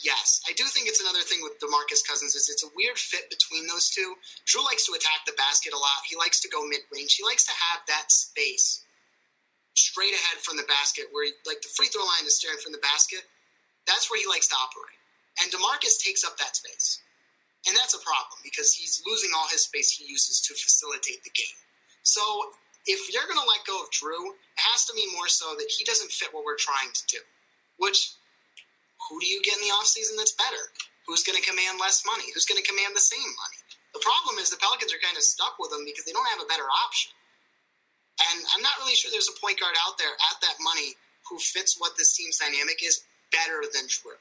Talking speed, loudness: 230 wpm, -24 LUFS